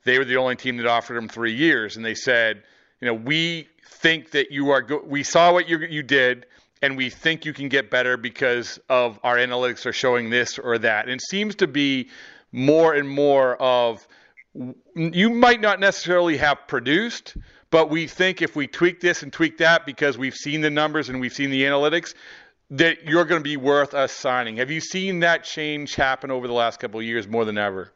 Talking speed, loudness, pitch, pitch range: 215 wpm, -21 LUFS, 140 Hz, 125-165 Hz